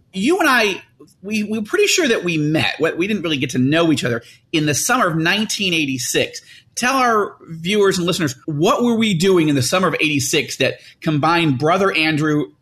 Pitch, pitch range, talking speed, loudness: 175 Hz, 155-215 Hz, 195 wpm, -17 LUFS